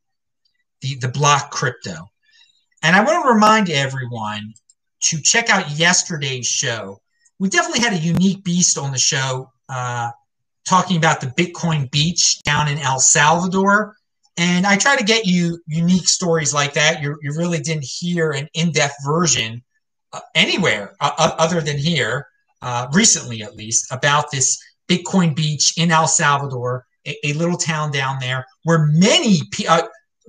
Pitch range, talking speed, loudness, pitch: 135-180 Hz, 160 wpm, -17 LUFS, 160 Hz